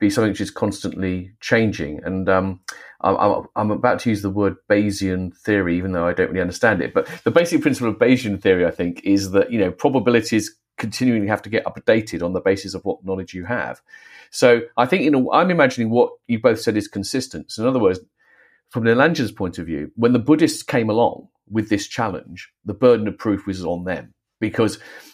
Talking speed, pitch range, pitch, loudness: 215 wpm, 95-120 Hz, 105 Hz, -20 LUFS